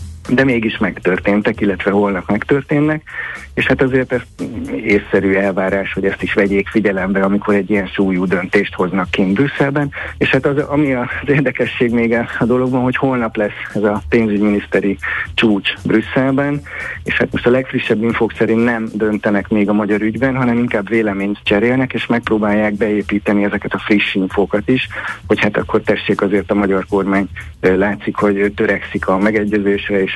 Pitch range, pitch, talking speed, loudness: 100-120 Hz, 105 Hz, 160 wpm, -16 LUFS